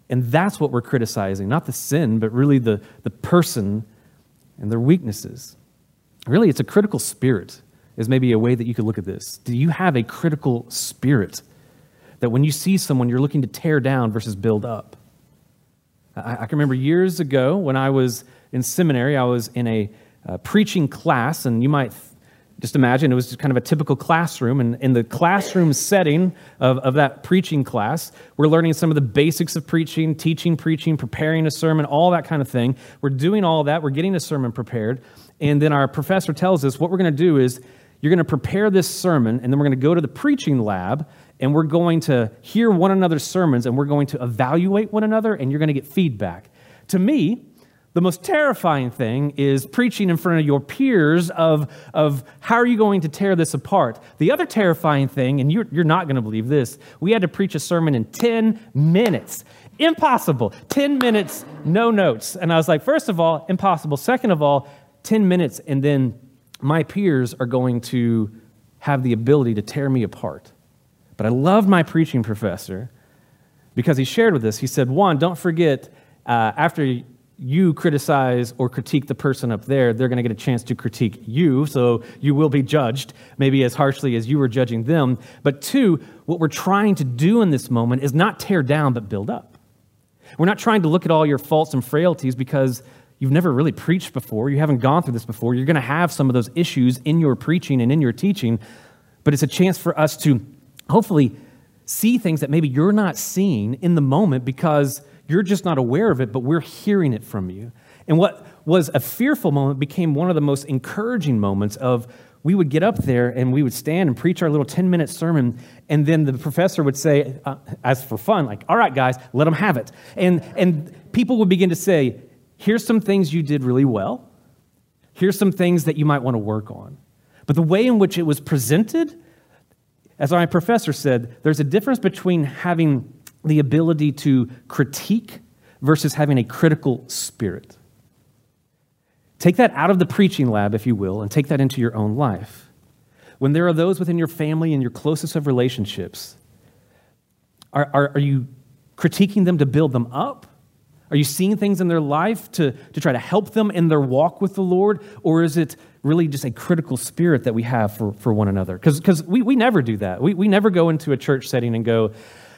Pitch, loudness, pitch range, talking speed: 145 Hz, -19 LUFS, 125-170 Hz, 210 wpm